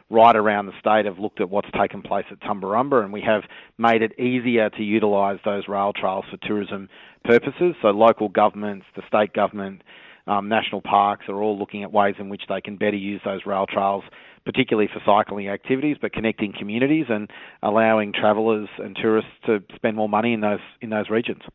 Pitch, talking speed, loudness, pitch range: 105 Hz, 195 wpm, -22 LUFS, 100-110 Hz